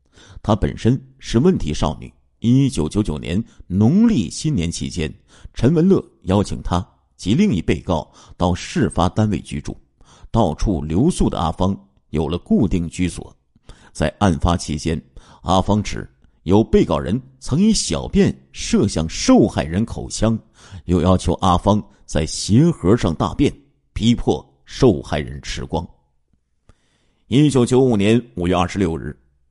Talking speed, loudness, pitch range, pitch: 205 characters per minute, -19 LUFS, 75-110 Hz, 90 Hz